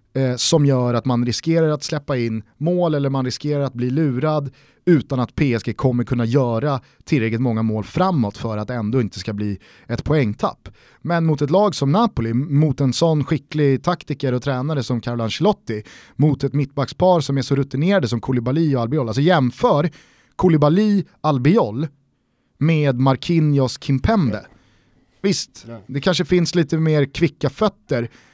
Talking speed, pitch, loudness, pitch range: 155 wpm, 140 Hz, -19 LUFS, 125-160 Hz